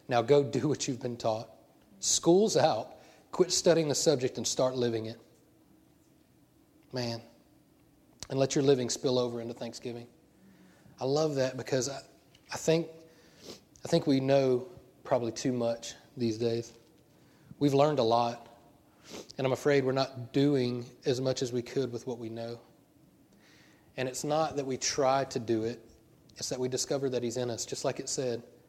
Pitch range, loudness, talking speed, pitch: 120-145 Hz, -30 LUFS, 170 wpm, 130 Hz